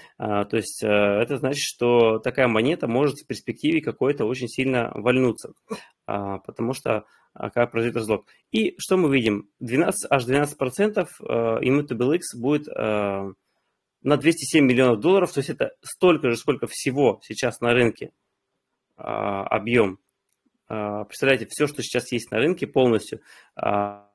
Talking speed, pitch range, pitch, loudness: 150 wpm, 110-140 Hz, 120 Hz, -23 LUFS